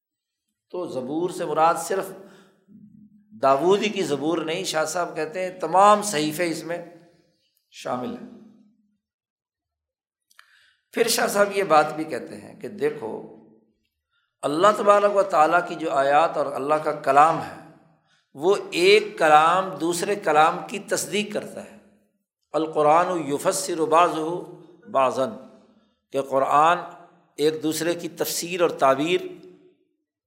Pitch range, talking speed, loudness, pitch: 160-210 Hz, 125 wpm, -22 LUFS, 175 Hz